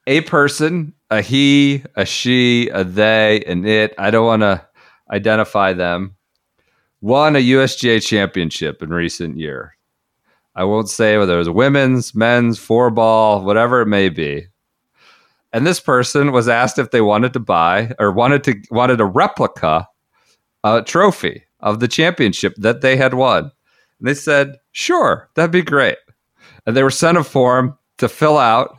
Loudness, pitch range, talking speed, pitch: -15 LUFS, 105-140 Hz, 160 wpm, 120 Hz